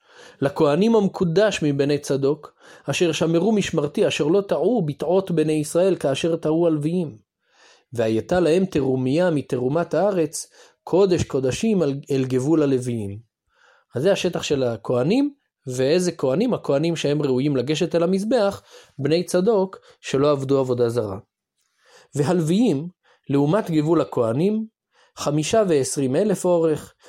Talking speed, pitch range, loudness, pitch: 120 wpm, 140-180 Hz, -21 LUFS, 155 Hz